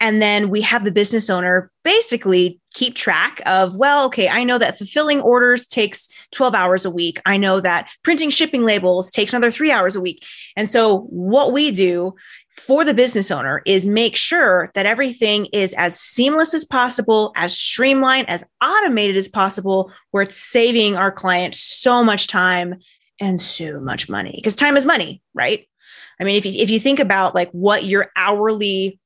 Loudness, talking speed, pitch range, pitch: -16 LUFS, 185 wpm, 185-250 Hz, 210 Hz